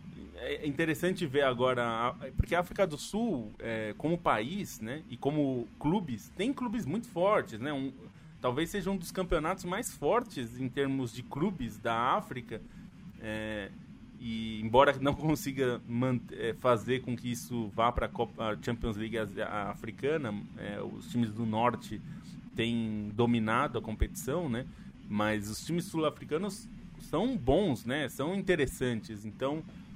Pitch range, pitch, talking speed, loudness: 115-170 Hz, 130 Hz, 145 wpm, -33 LUFS